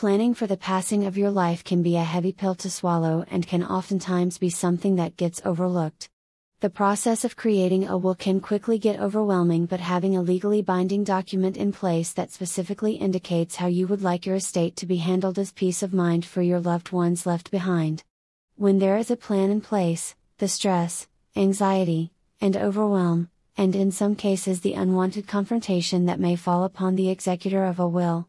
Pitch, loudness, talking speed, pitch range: 185 Hz, -24 LUFS, 190 wpm, 175-200 Hz